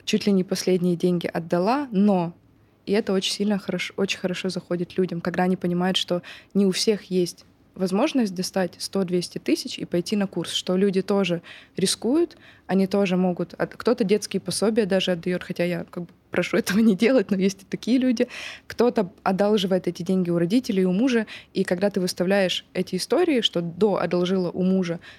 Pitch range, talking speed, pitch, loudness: 180-205 Hz, 180 wpm, 190 Hz, -23 LUFS